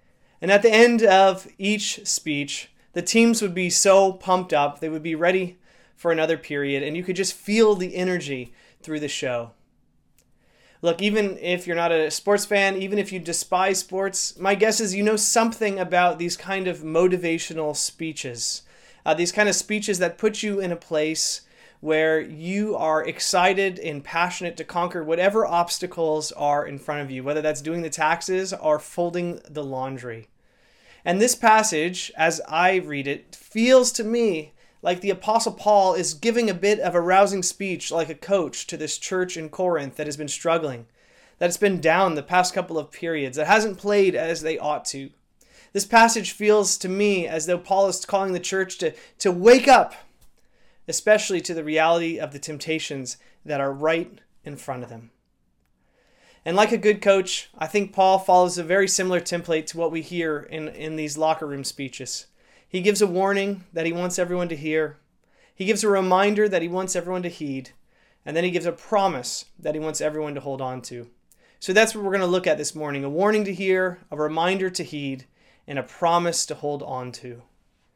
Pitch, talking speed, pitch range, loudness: 175 Hz, 195 wpm, 155-195 Hz, -22 LUFS